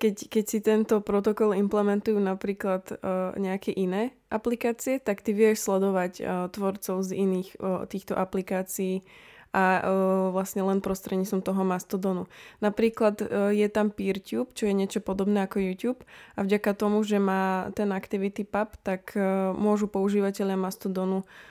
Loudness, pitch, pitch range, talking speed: -27 LUFS, 200 Hz, 190-210 Hz, 150 wpm